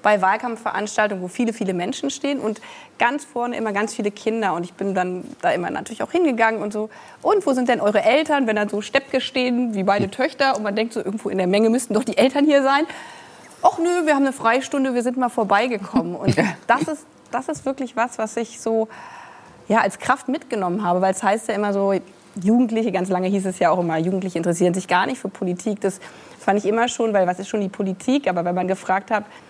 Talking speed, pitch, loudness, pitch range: 235 wpm, 220 Hz, -21 LUFS, 195-260 Hz